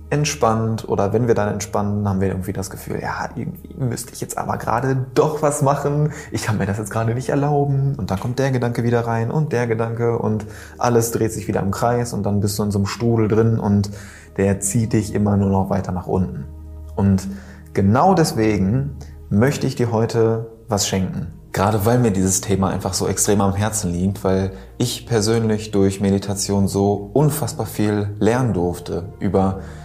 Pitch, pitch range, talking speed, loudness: 105 Hz, 95-115 Hz, 195 wpm, -20 LUFS